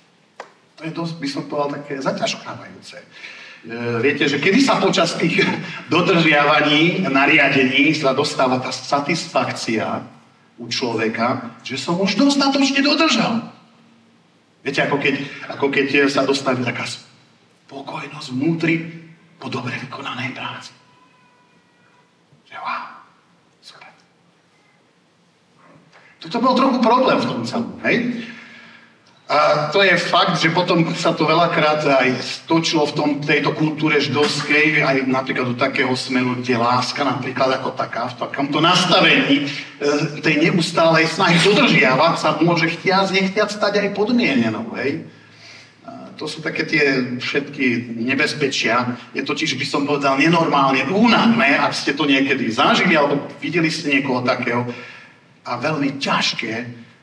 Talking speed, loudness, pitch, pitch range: 125 wpm, -17 LUFS, 150 Hz, 135-170 Hz